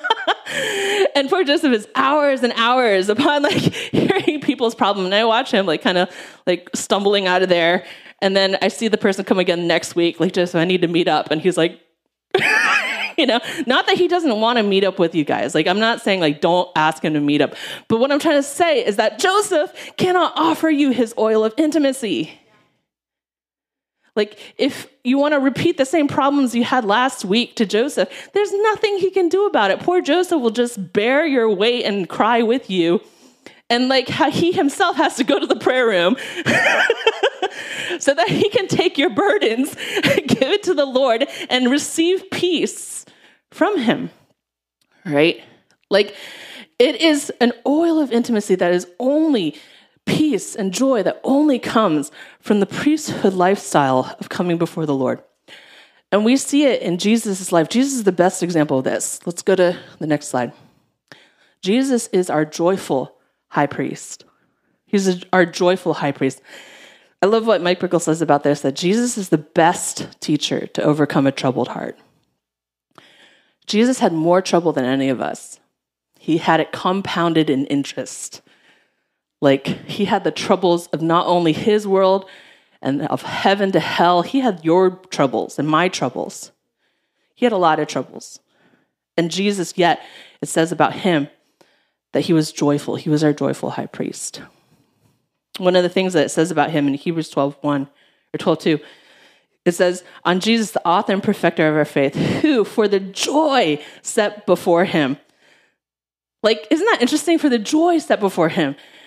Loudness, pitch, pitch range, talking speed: -18 LUFS, 200 Hz, 165-275 Hz, 180 wpm